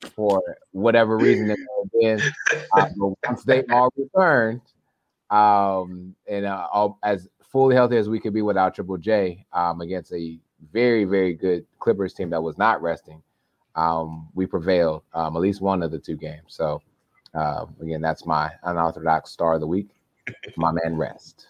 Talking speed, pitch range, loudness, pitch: 165 wpm, 80-110 Hz, -22 LUFS, 95 Hz